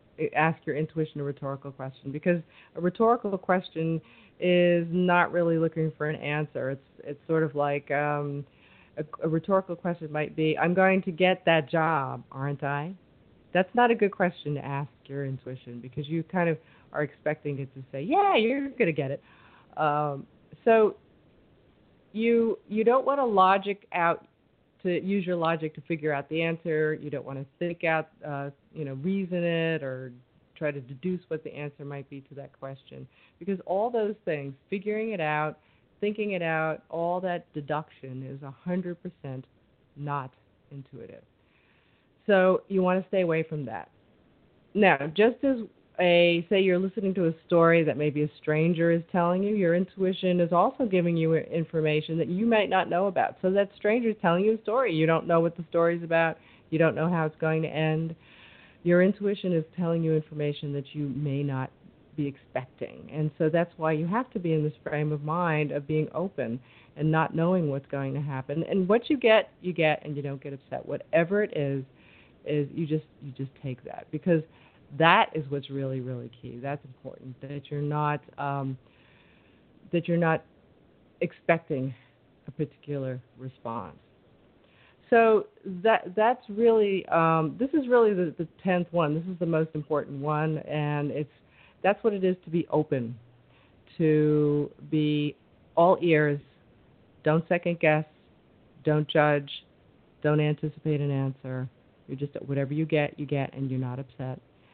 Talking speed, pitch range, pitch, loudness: 175 wpm, 140-175 Hz, 155 Hz, -27 LUFS